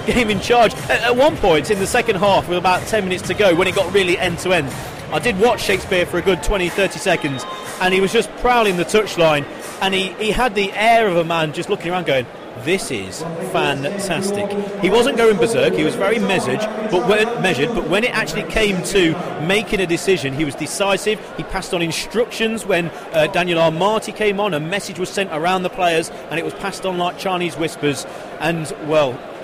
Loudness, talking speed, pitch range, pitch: -18 LUFS, 215 wpm, 170-210 Hz, 190 Hz